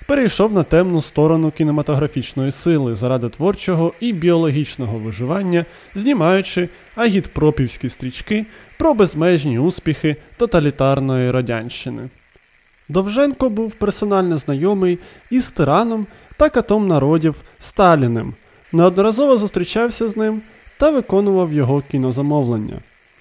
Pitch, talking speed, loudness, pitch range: 170 Hz, 95 wpm, -17 LUFS, 145-205 Hz